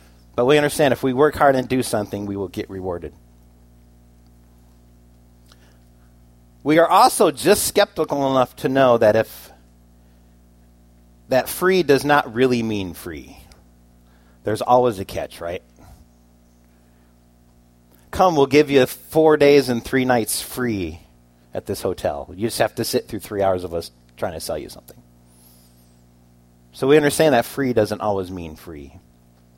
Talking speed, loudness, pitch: 150 wpm, -19 LUFS, 80 Hz